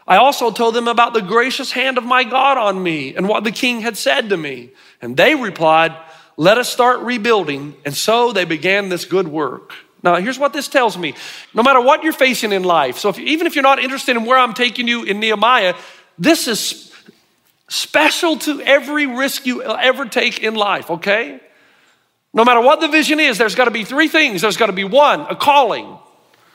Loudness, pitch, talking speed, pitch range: -15 LUFS, 235 Hz, 210 wpm, 195-270 Hz